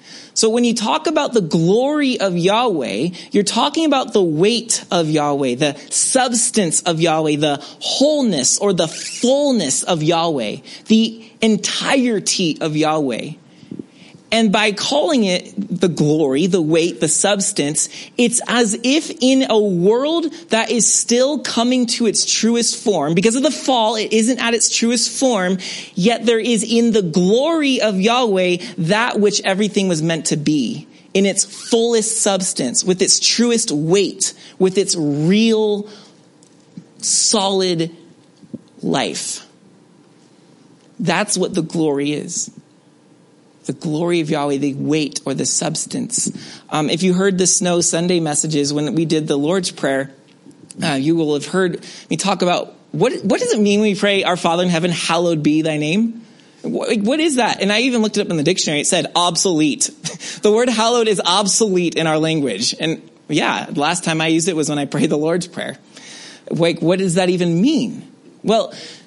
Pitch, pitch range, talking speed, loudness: 195 Hz, 165-230 Hz, 165 wpm, -16 LUFS